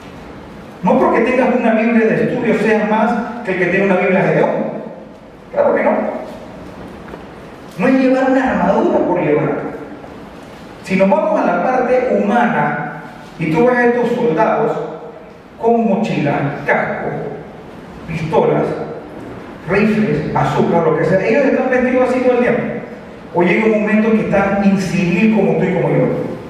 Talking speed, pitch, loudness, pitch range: 155 wpm, 220 Hz, -15 LUFS, 195-245 Hz